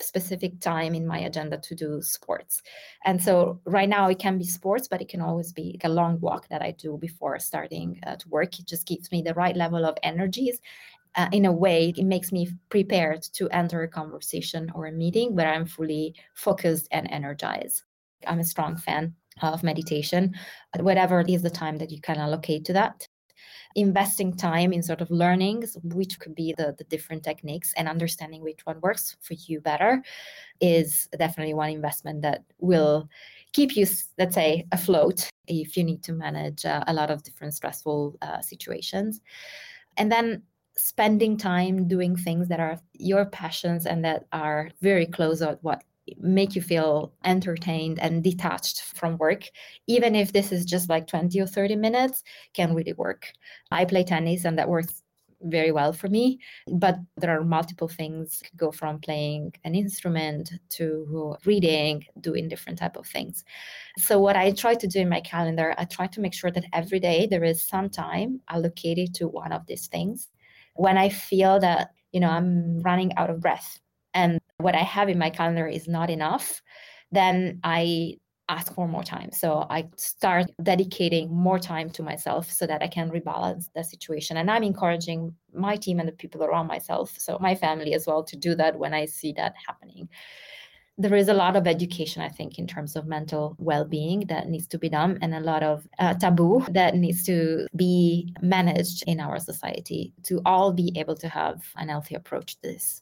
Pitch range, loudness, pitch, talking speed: 160-185 Hz, -26 LUFS, 170 Hz, 190 wpm